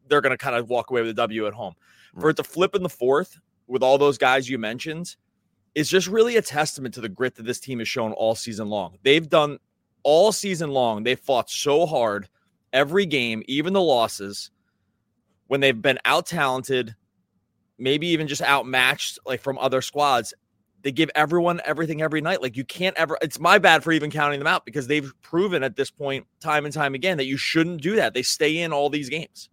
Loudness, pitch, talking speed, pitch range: -22 LUFS, 140 Hz, 215 wpm, 120-160 Hz